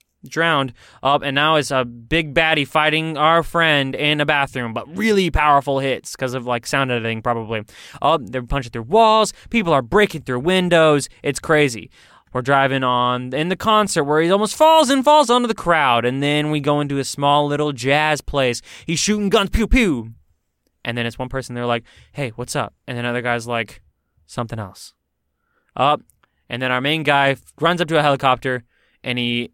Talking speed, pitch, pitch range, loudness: 200 wpm, 140 Hz, 120-160 Hz, -18 LUFS